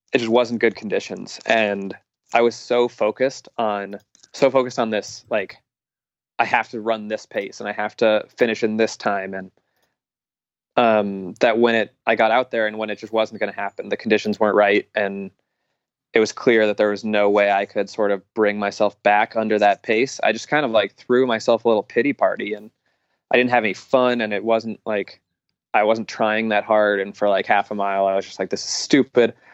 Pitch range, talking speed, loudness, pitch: 105-115 Hz, 220 wpm, -20 LUFS, 110 Hz